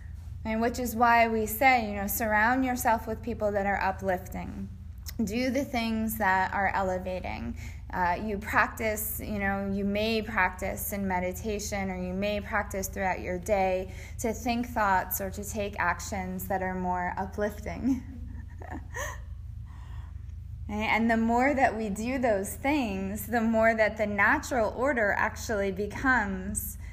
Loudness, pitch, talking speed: -28 LUFS, 195 Hz, 145 wpm